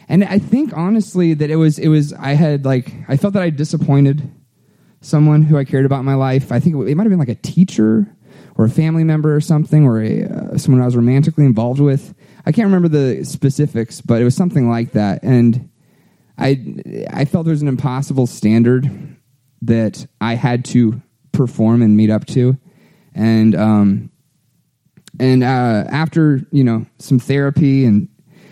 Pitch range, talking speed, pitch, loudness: 120-160 Hz, 185 wpm, 140 Hz, -15 LUFS